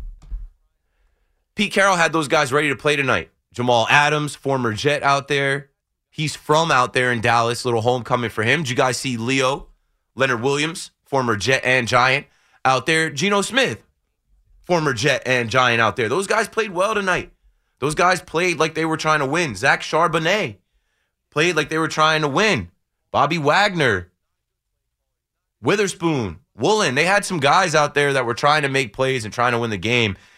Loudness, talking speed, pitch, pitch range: -19 LUFS, 180 wpm, 140 Hz, 120-155 Hz